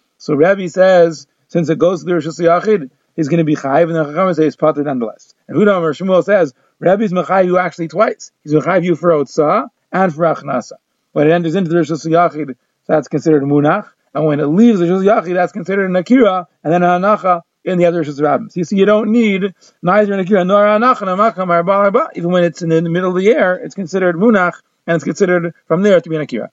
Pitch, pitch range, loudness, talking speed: 175 Hz, 160-195 Hz, -14 LUFS, 225 wpm